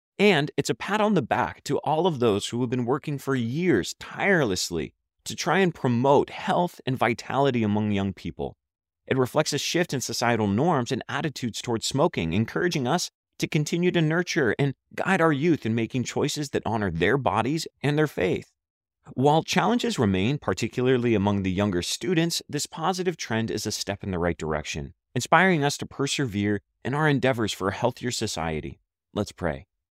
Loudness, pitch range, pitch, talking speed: -25 LUFS, 100-150 Hz, 125 Hz, 180 wpm